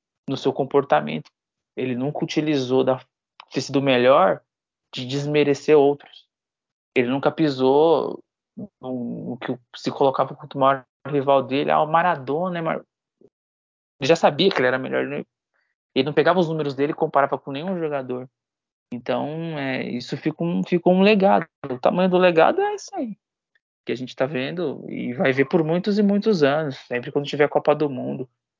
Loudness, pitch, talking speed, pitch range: -21 LUFS, 140 Hz, 165 wpm, 130-165 Hz